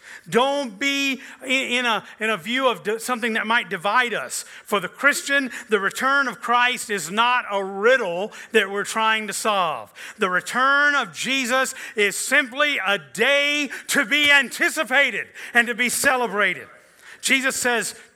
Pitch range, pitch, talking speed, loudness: 220-280 Hz, 245 Hz, 150 wpm, -20 LUFS